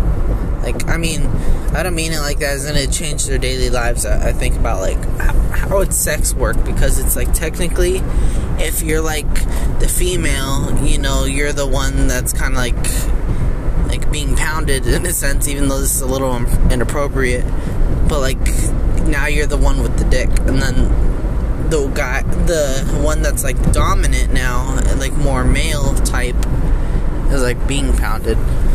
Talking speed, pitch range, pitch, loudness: 170 wpm, 120-140 Hz, 130 Hz, -18 LUFS